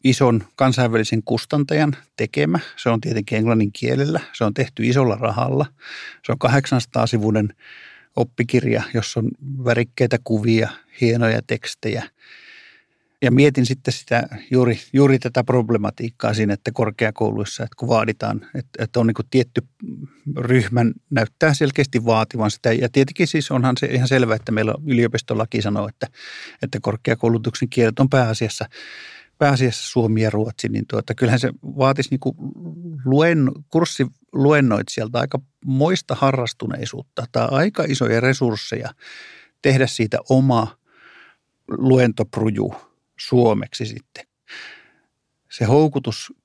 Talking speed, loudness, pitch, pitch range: 120 wpm, -20 LUFS, 125 Hz, 115-135 Hz